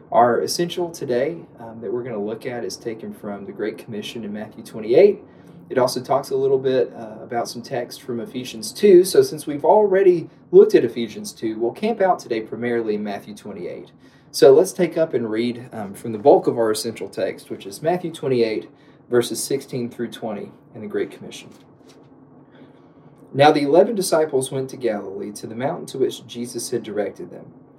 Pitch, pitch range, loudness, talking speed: 135 Hz, 115-180 Hz, -20 LUFS, 195 wpm